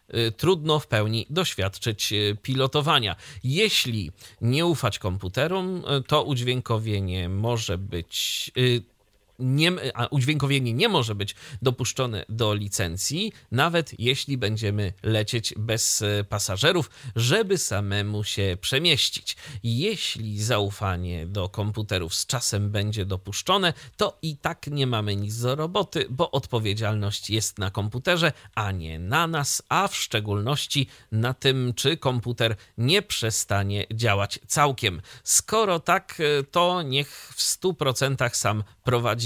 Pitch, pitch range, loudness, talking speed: 120 Hz, 105-140 Hz, -25 LUFS, 120 wpm